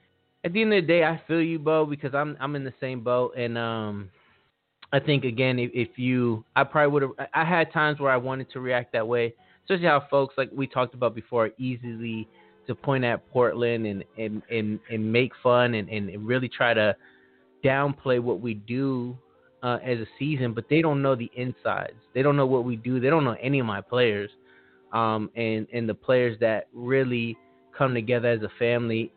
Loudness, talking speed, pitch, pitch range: -25 LUFS, 210 wpm, 125 Hz, 115-135 Hz